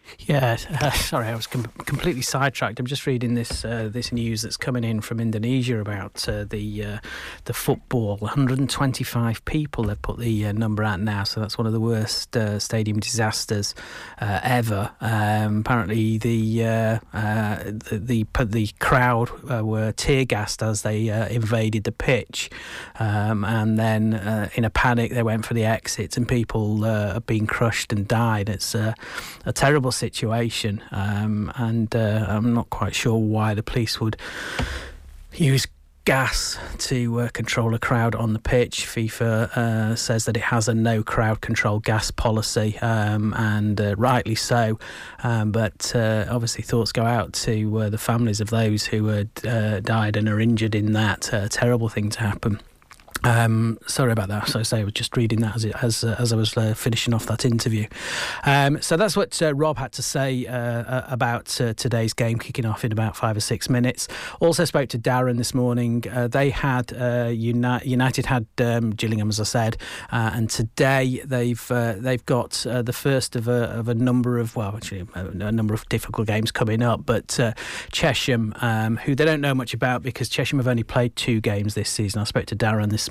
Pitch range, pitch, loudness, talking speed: 110-125 Hz, 115 Hz, -23 LUFS, 195 wpm